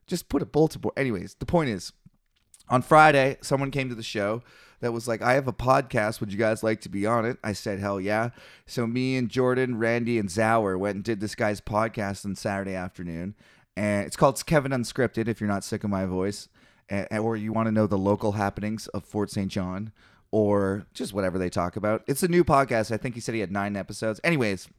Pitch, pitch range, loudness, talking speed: 110 Hz, 100-125 Hz, -26 LUFS, 230 wpm